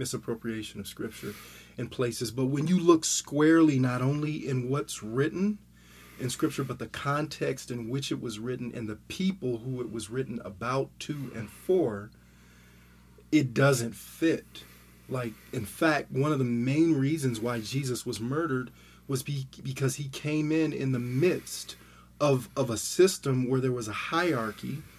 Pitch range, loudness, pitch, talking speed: 115-140 Hz, -29 LUFS, 130 Hz, 165 wpm